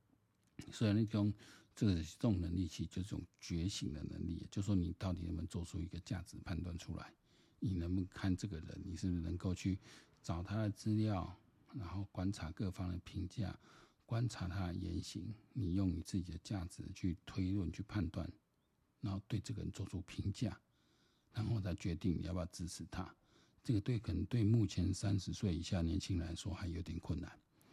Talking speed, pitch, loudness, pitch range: 290 characters per minute, 95 Hz, -42 LUFS, 90-105 Hz